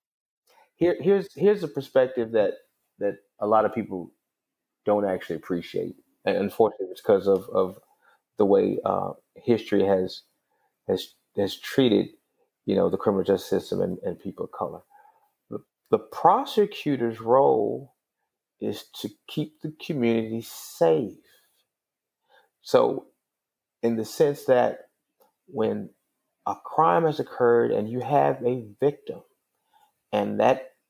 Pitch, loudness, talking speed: 130 Hz, -25 LUFS, 125 wpm